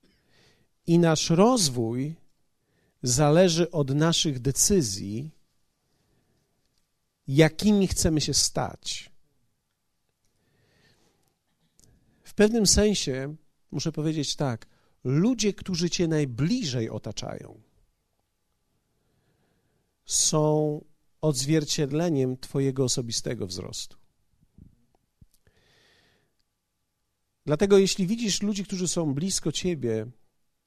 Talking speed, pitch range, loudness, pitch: 70 wpm, 115-175 Hz, -25 LUFS, 150 Hz